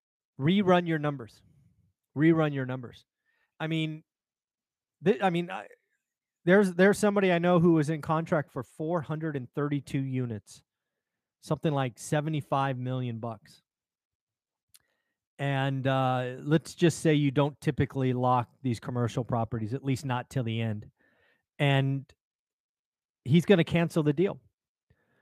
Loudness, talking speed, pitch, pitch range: -28 LUFS, 130 wpm, 145 Hz, 130-165 Hz